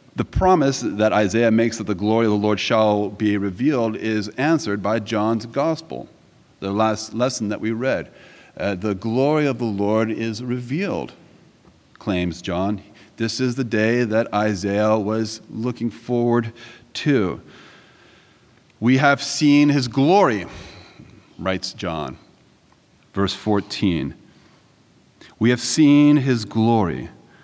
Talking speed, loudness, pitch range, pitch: 130 wpm, -20 LUFS, 105-125 Hz, 110 Hz